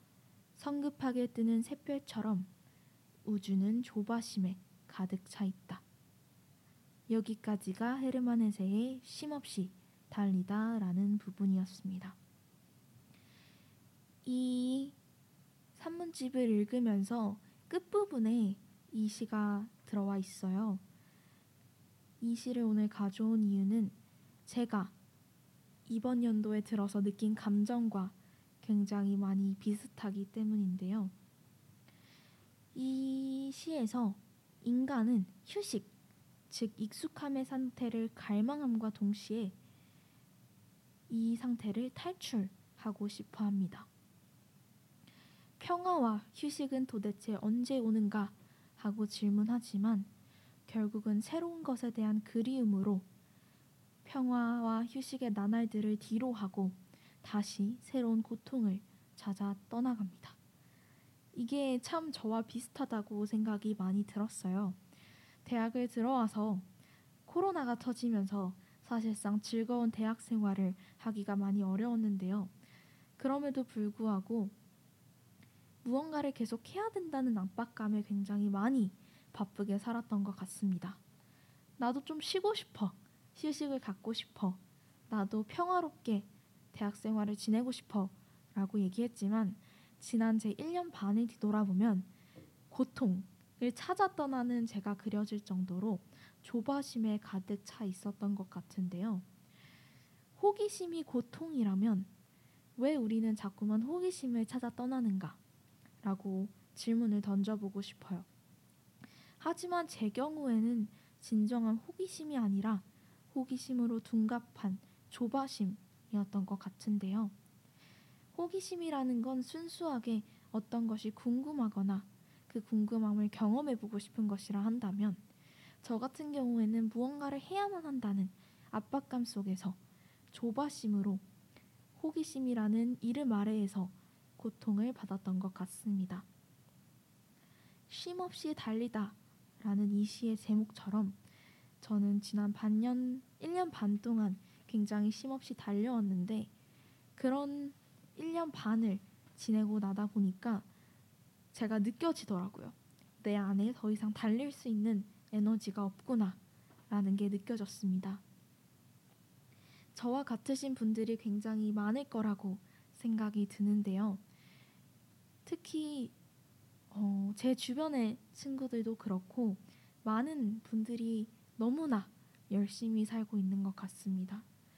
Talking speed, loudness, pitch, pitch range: 240 characters per minute, -37 LUFS, 215 Hz, 200-245 Hz